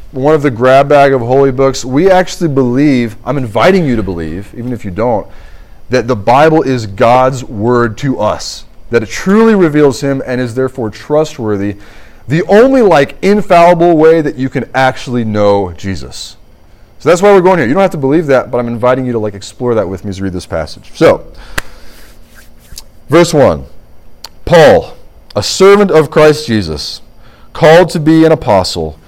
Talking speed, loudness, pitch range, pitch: 185 wpm, -10 LUFS, 110-155 Hz, 130 Hz